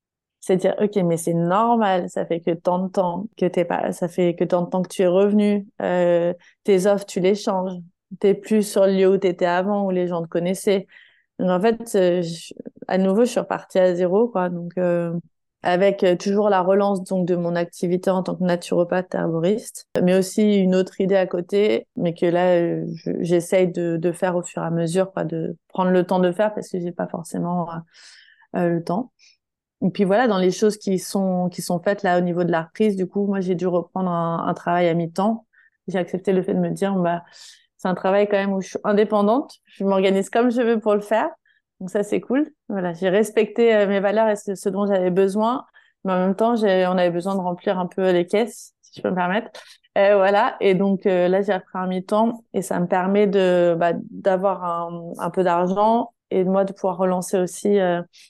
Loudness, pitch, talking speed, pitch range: -21 LUFS, 190 Hz, 240 wpm, 180-205 Hz